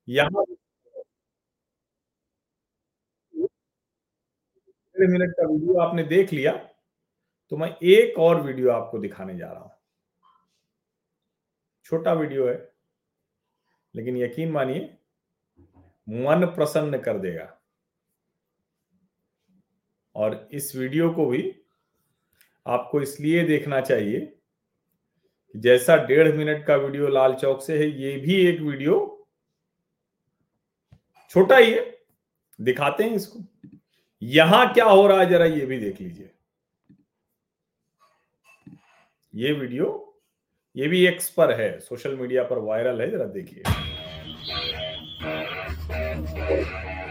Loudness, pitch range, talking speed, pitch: -22 LUFS, 125-195 Hz, 100 wpm, 160 Hz